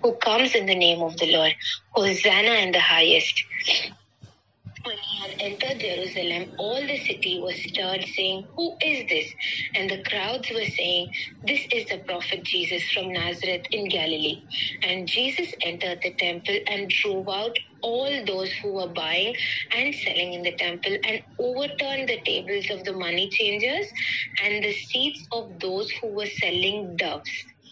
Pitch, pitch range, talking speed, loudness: 195 Hz, 180-230 Hz, 160 wpm, -24 LUFS